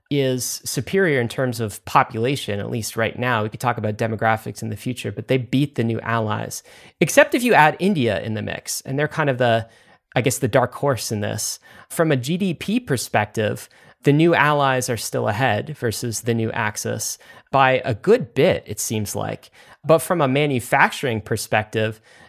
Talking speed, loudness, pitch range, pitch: 190 wpm, -21 LUFS, 110-140 Hz, 125 Hz